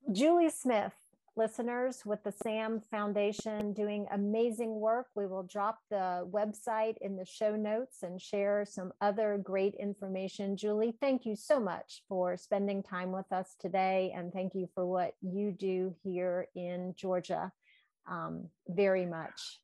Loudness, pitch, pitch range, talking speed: -35 LUFS, 200 Hz, 185-220 Hz, 150 wpm